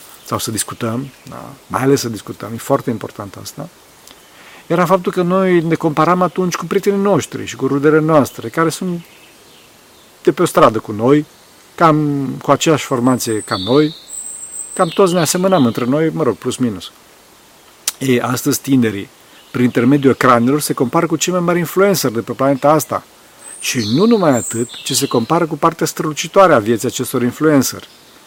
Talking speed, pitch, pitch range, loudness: 170 wpm, 140 Hz, 125-165 Hz, -15 LUFS